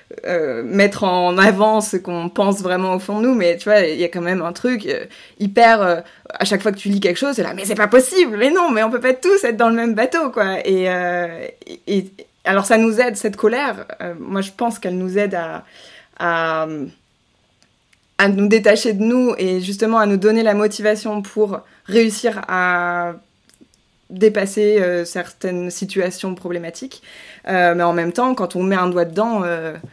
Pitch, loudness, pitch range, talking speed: 200 Hz, -17 LUFS, 180-225 Hz, 205 wpm